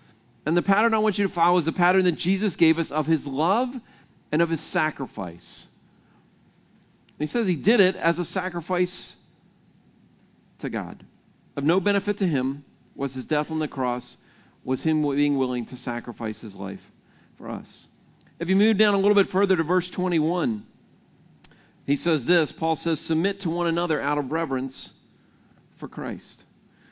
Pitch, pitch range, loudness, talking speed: 165 Hz, 145-185 Hz, -24 LUFS, 175 wpm